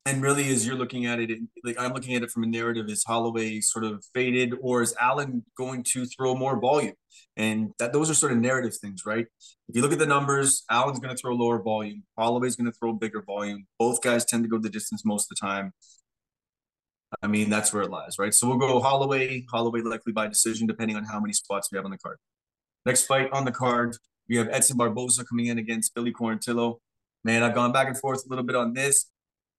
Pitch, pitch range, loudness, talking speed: 120 Hz, 110-125 Hz, -25 LUFS, 235 wpm